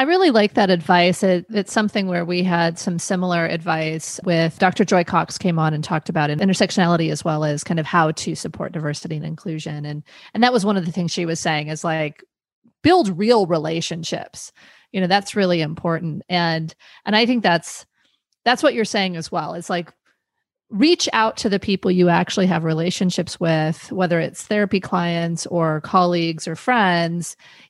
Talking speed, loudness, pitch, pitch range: 190 wpm, -20 LUFS, 175 Hz, 165-200 Hz